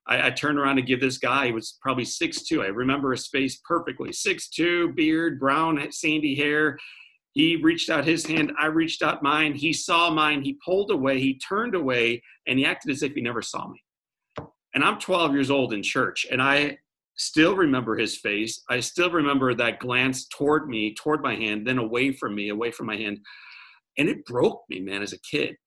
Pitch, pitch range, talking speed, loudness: 140 Hz, 125-160 Hz, 210 wpm, -24 LUFS